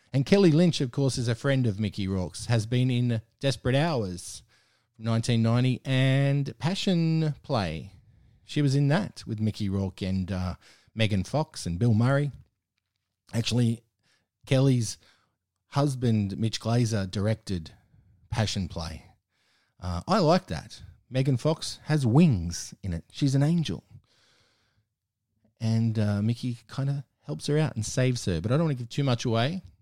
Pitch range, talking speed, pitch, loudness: 105-135 Hz, 150 wpm, 115 Hz, -27 LUFS